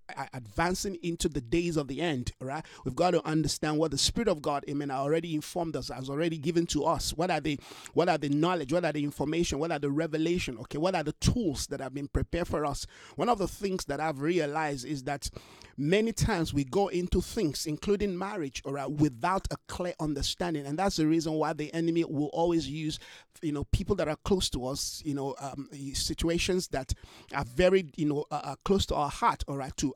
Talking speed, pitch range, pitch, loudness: 225 wpm, 140-175 Hz, 155 Hz, -31 LUFS